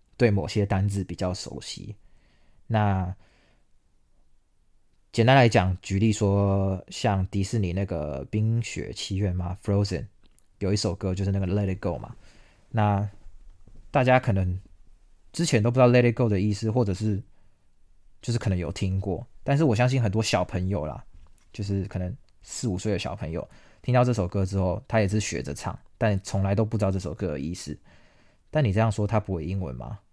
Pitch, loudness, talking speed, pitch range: 100 Hz, -26 LUFS, 280 characters per minute, 90-110 Hz